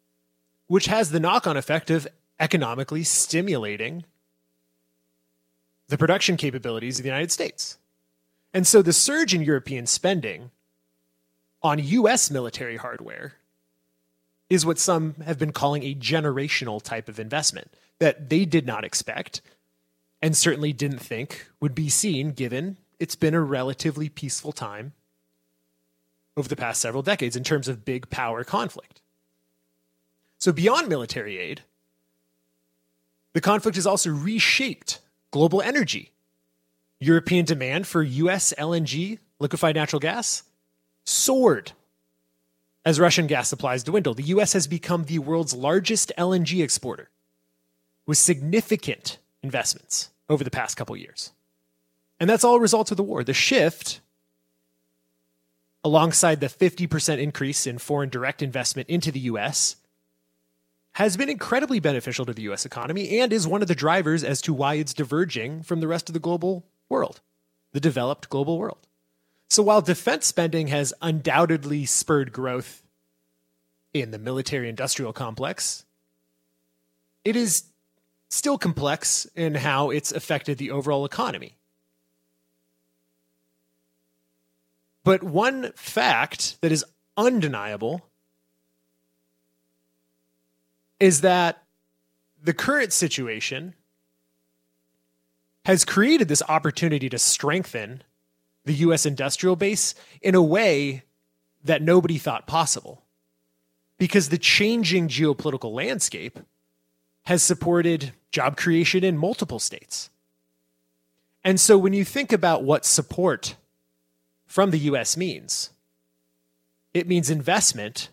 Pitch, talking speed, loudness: 135 Hz, 120 wpm, -23 LUFS